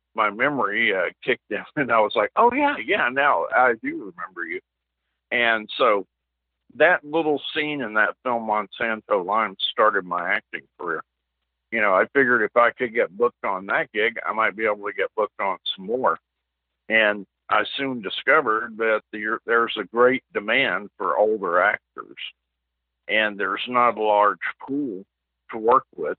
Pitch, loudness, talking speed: 110 Hz, -22 LUFS, 170 wpm